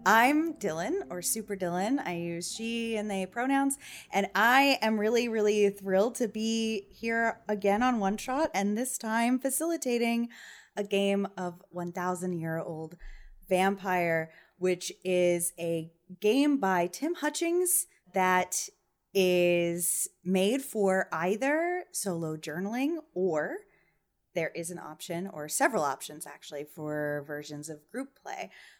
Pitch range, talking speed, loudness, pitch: 175-240 Hz, 125 wpm, -29 LUFS, 195 Hz